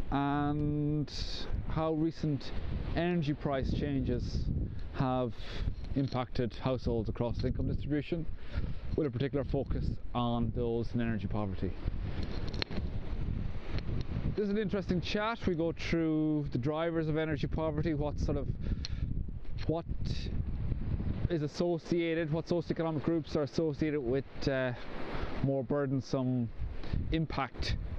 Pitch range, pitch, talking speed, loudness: 110-155 Hz, 135 Hz, 110 wpm, -35 LUFS